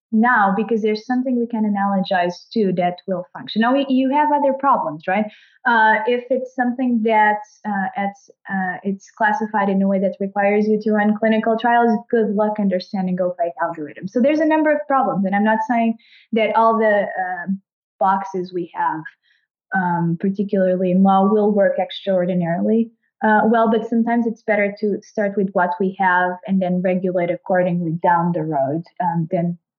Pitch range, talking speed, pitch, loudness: 185-225 Hz, 180 wpm, 205 Hz, -19 LUFS